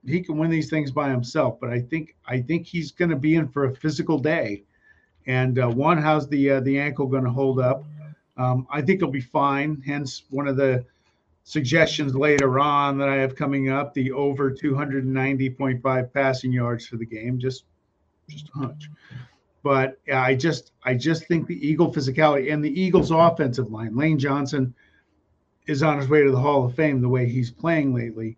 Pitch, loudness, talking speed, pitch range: 140 Hz, -23 LUFS, 195 wpm, 130-150 Hz